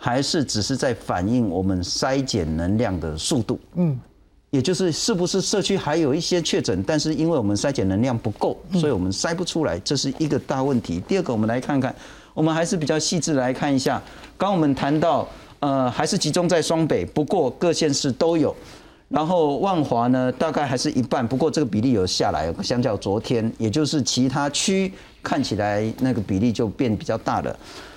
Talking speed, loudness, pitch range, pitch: 305 characters per minute, -22 LUFS, 120-165 Hz, 145 Hz